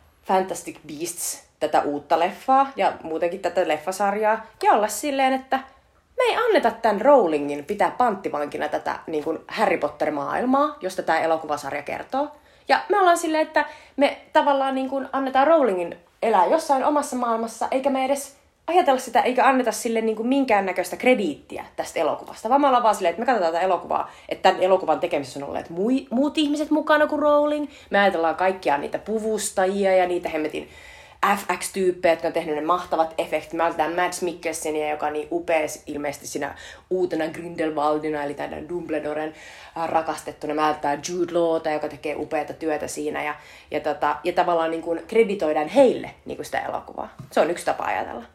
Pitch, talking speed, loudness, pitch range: 185 Hz, 170 wpm, -23 LUFS, 160-265 Hz